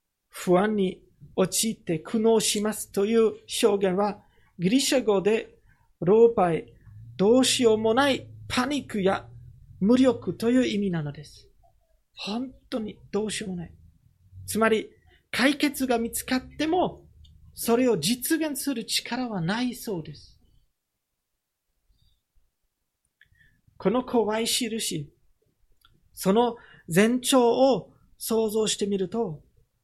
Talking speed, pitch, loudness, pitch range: 215 characters per minute, 215 Hz, -25 LUFS, 180-240 Hz